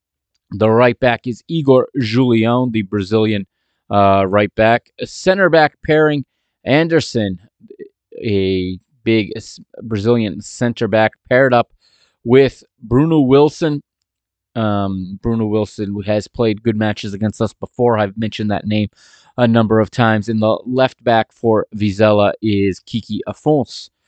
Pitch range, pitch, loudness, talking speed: 105-125 Hz, 110 Hz, -16 LUFS, 130 wpm